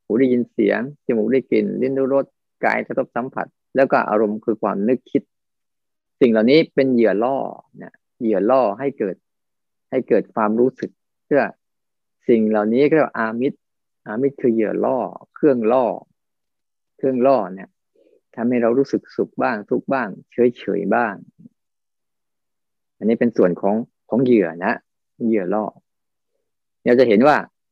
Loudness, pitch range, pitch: -19 LUFS, 110-135 Hz, 120 Hz